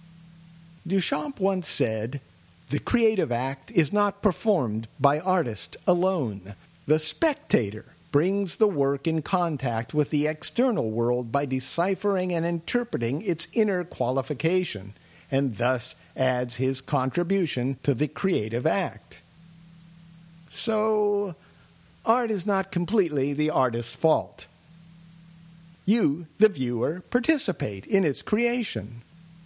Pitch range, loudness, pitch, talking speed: 135-190 Hz, -26 LUFS, 165 Hz, 110 wpm